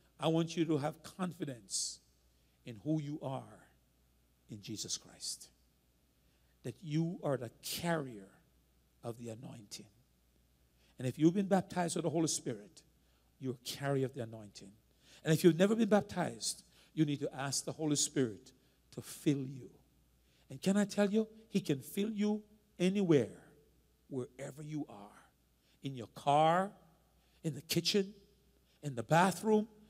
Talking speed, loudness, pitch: 150 wpm, -35 LUFS, 140 Hz